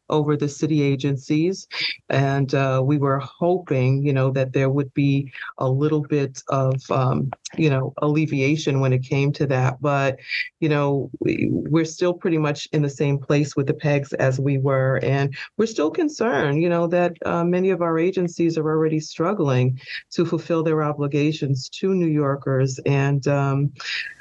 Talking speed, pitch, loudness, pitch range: 175 wpm, 145 Hz, -22 LUFS, 135-160 Hz